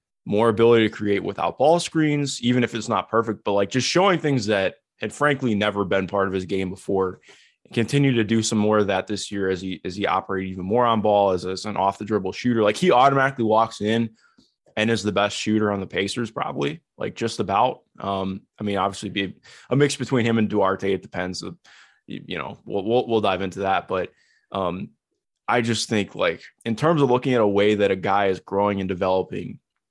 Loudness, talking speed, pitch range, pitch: -22 LUFS, 225 wpm, 95-115 Hz, 105 Hz